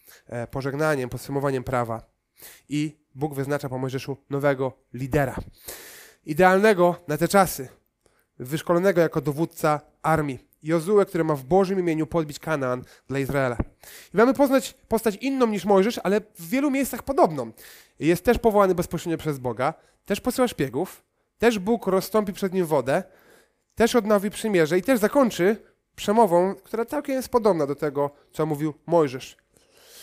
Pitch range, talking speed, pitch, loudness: 140-210 Hz, 140 wpm, 165 Hz, -24 LUFS